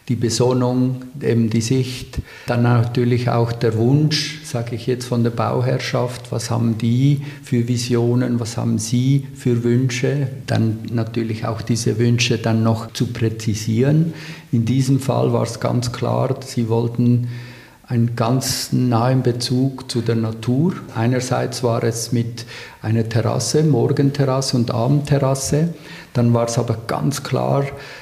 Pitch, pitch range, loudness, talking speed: 120 Hz, 115-130 Hz, -19 LUFS, 140 wpm